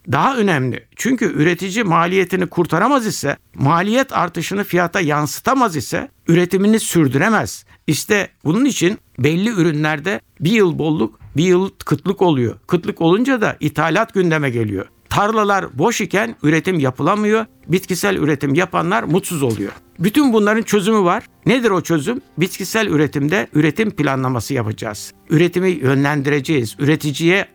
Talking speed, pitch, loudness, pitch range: 125 wpm, 170 Hz, -17 LUFS, 145-200 Hz